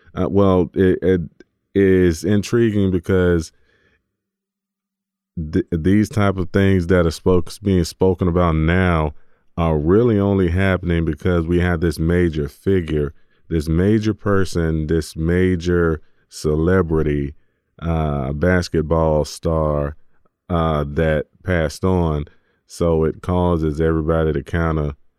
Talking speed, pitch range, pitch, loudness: 115 wpm, 80-95 Hz, 85 Hz, -19 LUFS